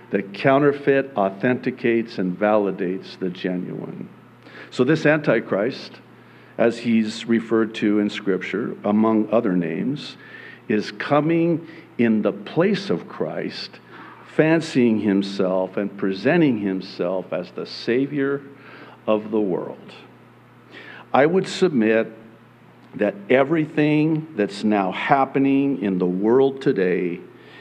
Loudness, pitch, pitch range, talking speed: -21 LUFS, 115 Hz, 100-140 Hz, 105 wpm